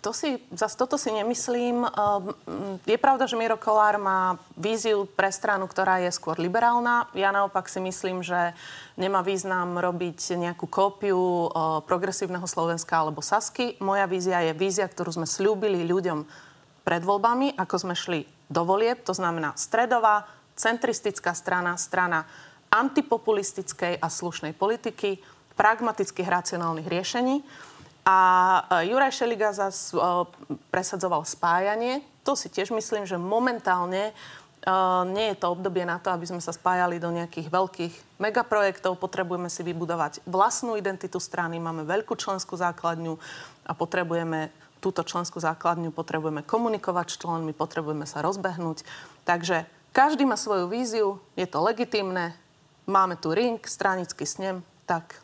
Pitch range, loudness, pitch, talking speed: 170-210 Hz, -26 LUFS, 185 Hz, 135 wpm